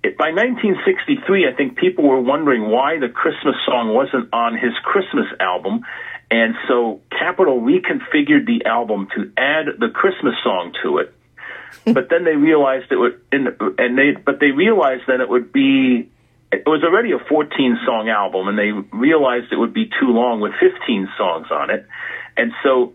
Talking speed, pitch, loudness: 180 wpm, 140 Hz, -17 LUFS